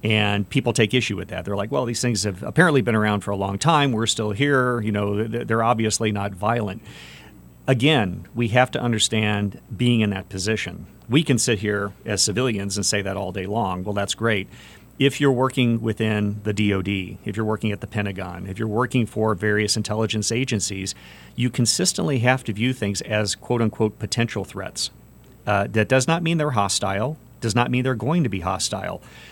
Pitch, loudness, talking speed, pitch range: 110 Hz, -22 LUFS, 200 wpm, 100-120 Hz